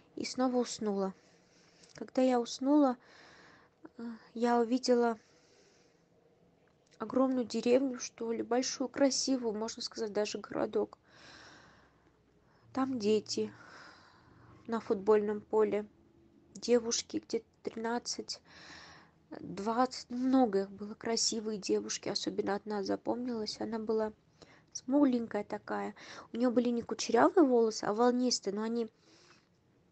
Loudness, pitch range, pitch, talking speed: -33 LUFS, 210-250 Hz, 230 Hz, 95 wpm